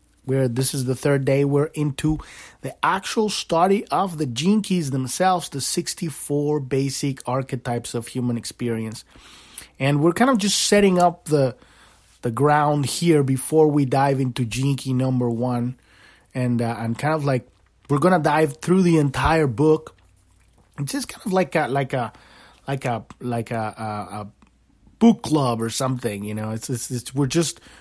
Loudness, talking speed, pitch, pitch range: -21 LUFS, 170 wpm, 135 Hz, 120-155 Hz